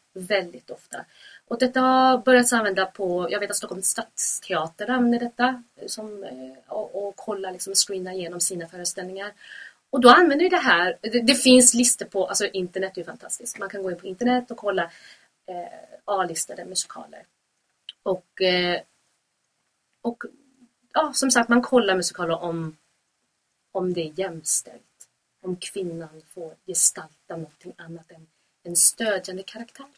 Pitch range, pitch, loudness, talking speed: 180-240 Hz, 195 Hz, -22 LUFS, 150 wpm